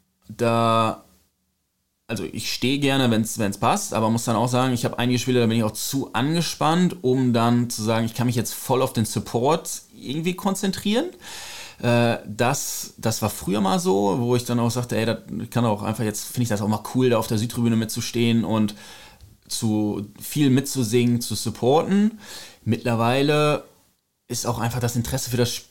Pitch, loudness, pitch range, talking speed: 120 Hz, -23 LUFS, 110-130 Hz, 185 wpm